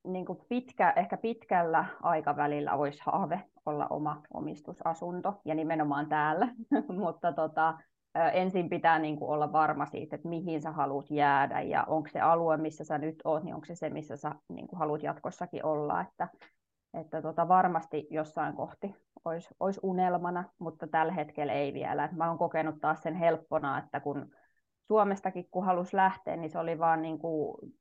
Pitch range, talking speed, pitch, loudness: 155-180 Hz, 170 wpm, 165 Hz, -32 LUFS